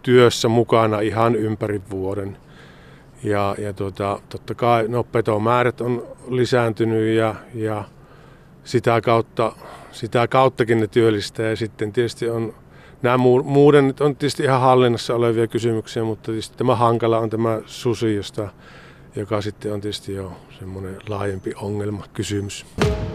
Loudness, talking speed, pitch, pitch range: -20 LUFS, 130 wpm, 115 Hz, 105-120 Hz